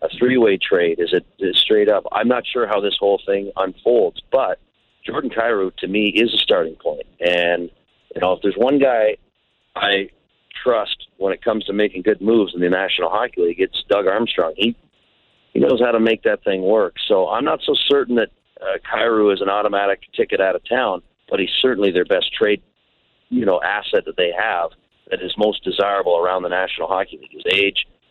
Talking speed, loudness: 205 wpm, -18 LUFS